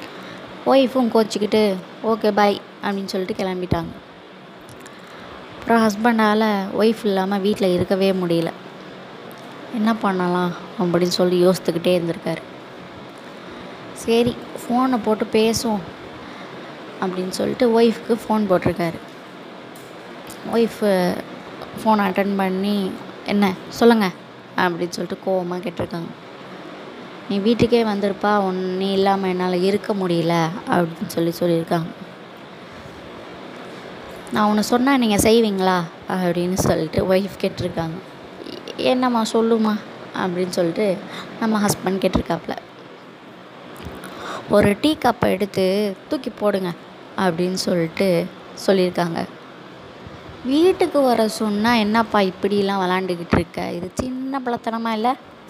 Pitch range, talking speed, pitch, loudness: 180-225 Hz, 90 wpm, 200 Hz, -20 LUFS